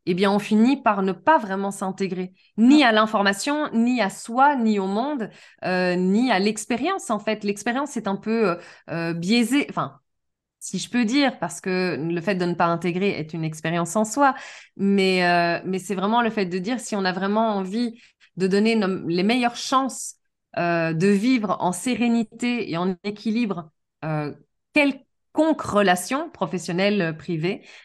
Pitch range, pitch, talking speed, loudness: 185-235 Hz, 200 Hz, 170 wpm, -22 LUFS